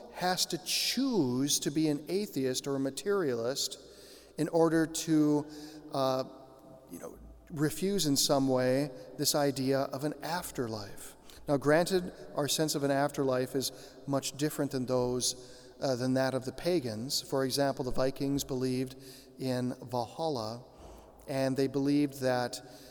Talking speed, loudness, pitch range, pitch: 140 wpm, -31 LUFS, 130-150 Hz, 135 Hz